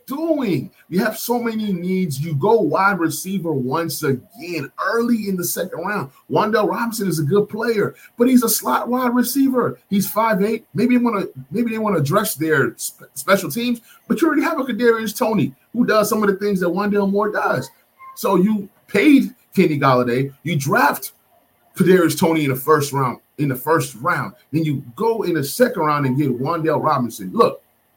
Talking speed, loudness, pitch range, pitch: 195 wpm, -19 LUFS, 155-230 Hz, 195 Hz